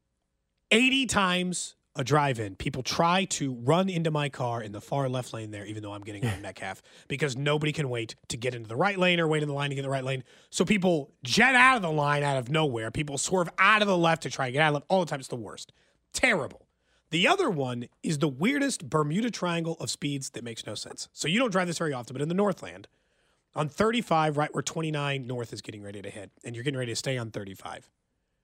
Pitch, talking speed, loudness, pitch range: 145 Hz, 255 wpm, -27 LUFS, 120-170 Hz